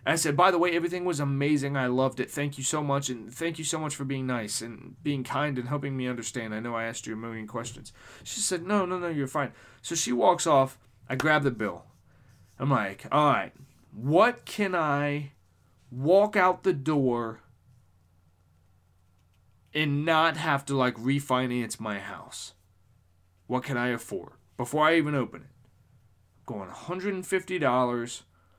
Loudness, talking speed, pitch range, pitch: -27 LUFS, 175 wpm, 115-155 Hz, 130 Hz